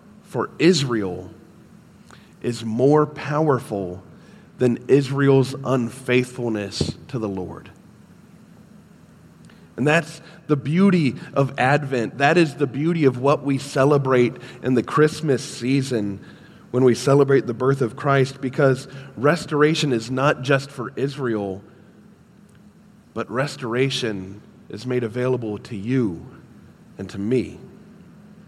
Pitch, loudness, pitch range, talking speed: 135 Hz, -21 LUFS, 120-150 Hz, 110 wpm